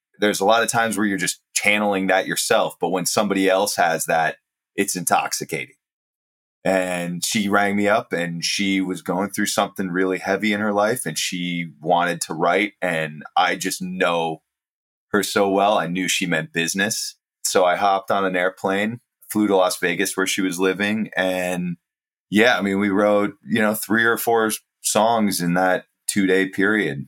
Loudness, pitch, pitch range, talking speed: -20 LUFS, 95 Hz, 90-105 Hz, 185 wpm